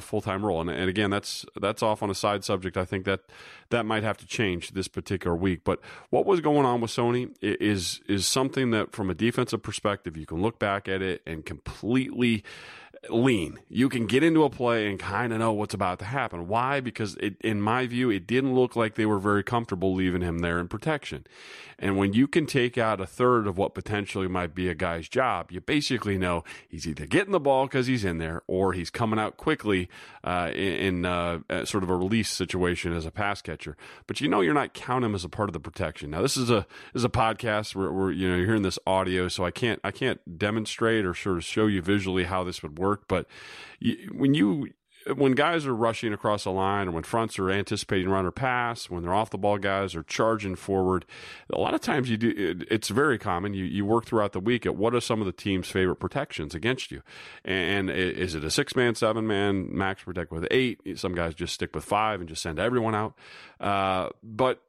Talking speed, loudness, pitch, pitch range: 230 wpm, -27 LUFS, 100 Hz, 95-115 Hz